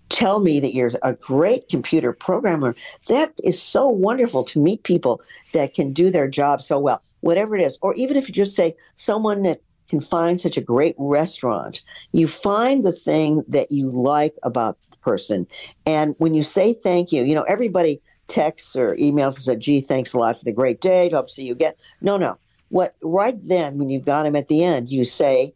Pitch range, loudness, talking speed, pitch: 140-185 Hz, -20 LUFS, 210 wpm, 160 Hz